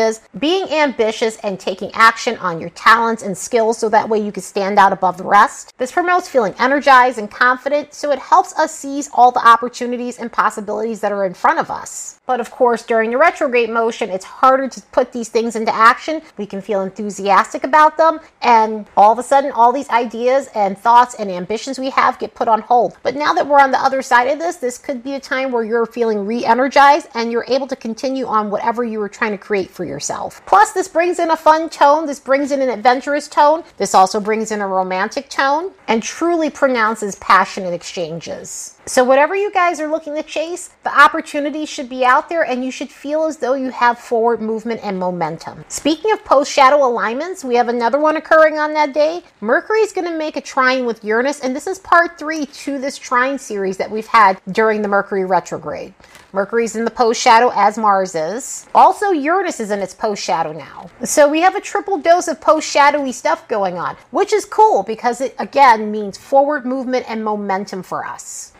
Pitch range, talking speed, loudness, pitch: 220-295 Hz, 215 wpm, -16 LUFS, 245 Hz